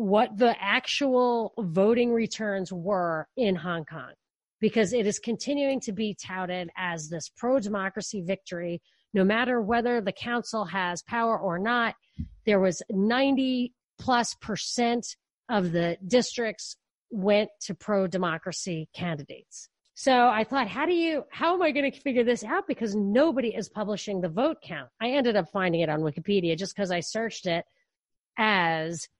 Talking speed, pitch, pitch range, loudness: 160 wpm, 215 Hz, 185-240 Hz, -27 LUFS